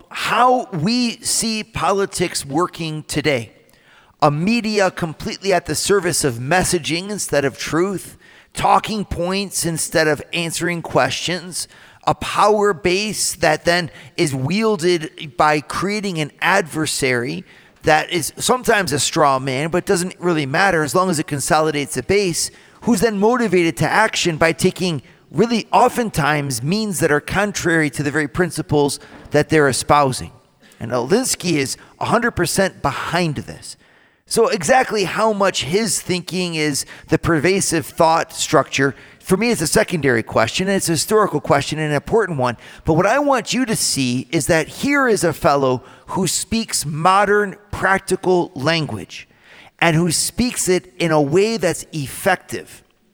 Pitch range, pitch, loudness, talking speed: 150-195 Hz, 170 Hz, -18 LUFS, 145 wpm